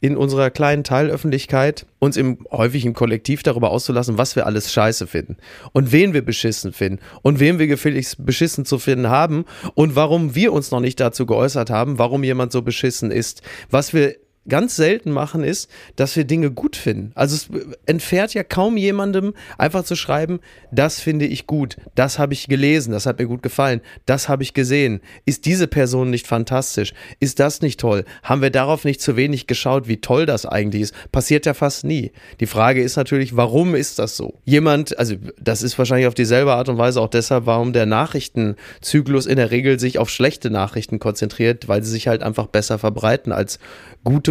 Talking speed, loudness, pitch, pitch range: 195 wpm, -18 LUFS, 130 Hz, 115-145 Hz